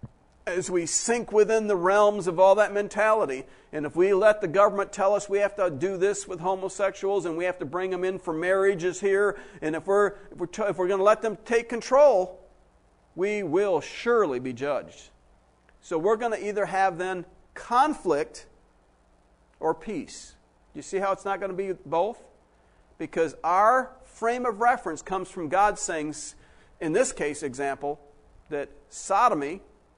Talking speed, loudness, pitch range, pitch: 175 wpm, -25 LUFS, 160-205 Hz, 190 Hz